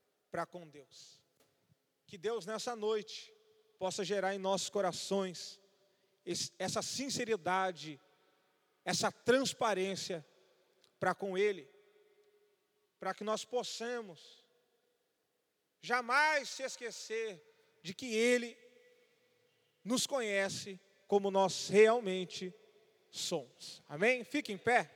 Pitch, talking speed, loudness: 220 Hz, 95 wpm, -35 LUFS